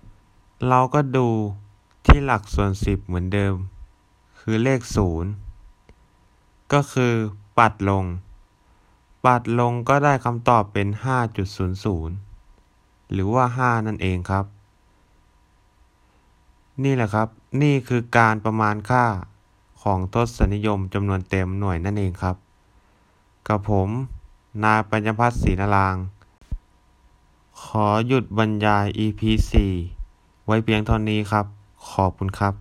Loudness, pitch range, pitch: -22 LUFS, 95-110 Hz, 105 Hz